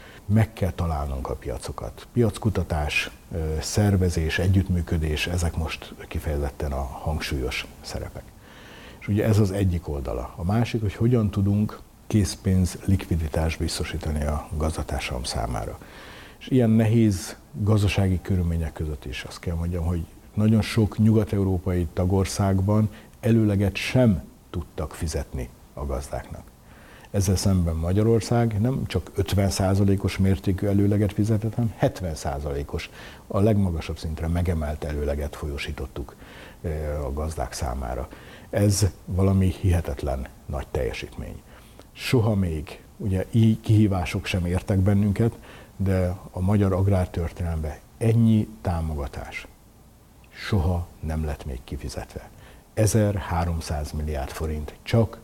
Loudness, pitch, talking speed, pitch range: -25 LUFS, 95 Hz, 110 wpm, 80-105 Hz